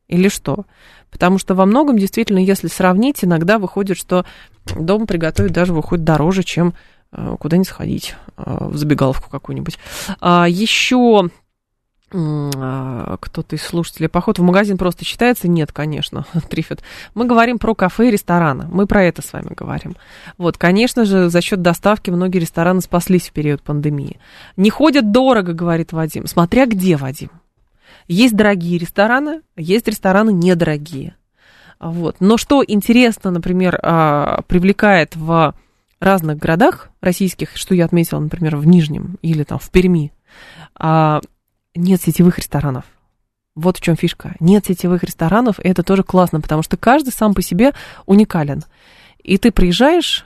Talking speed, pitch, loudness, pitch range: 140 wpm, 180 Hz, -15 LUFS, 160-200 Hz